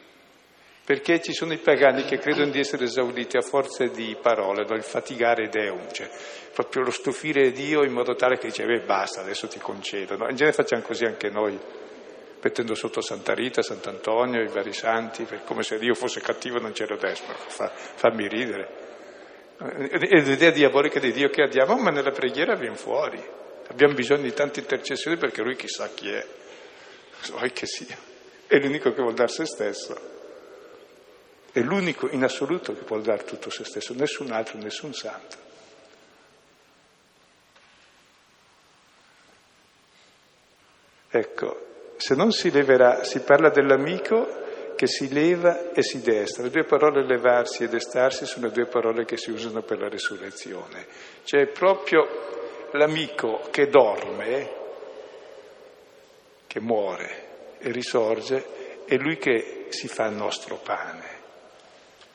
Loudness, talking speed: -24 LUFS, 150 wpm